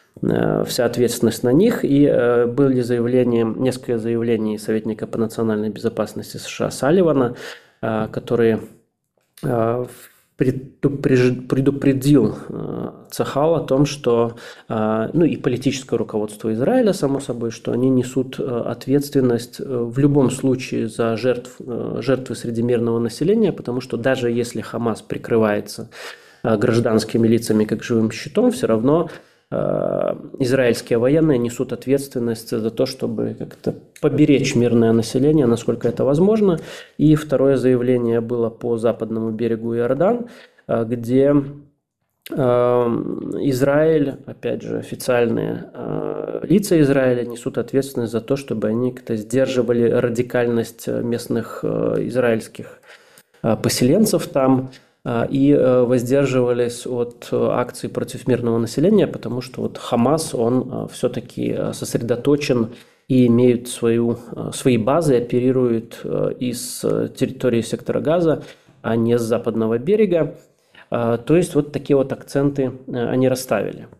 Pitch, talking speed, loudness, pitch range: 125 Hz, 110 wpm, -19 LUFS, 115-140 Hz